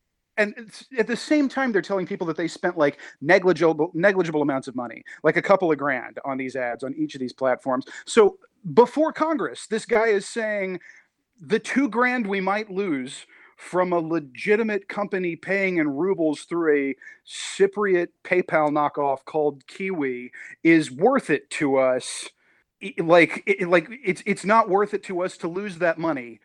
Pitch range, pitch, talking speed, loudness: 155-210 Hz, 185 Hz, 170 wpm, -23 LUFS